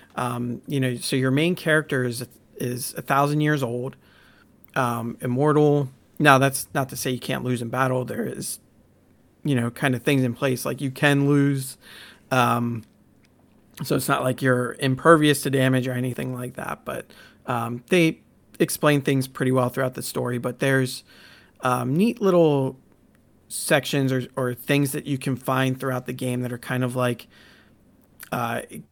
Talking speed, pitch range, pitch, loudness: 170 wpm, 125-140 Hz, 130 Hz, -23 LUFS